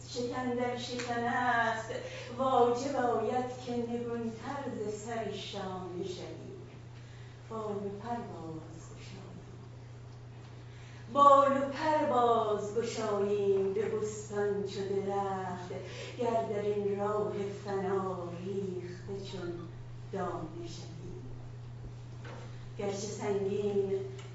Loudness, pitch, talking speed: -33 LUFS, 200 Hz, 85 wpm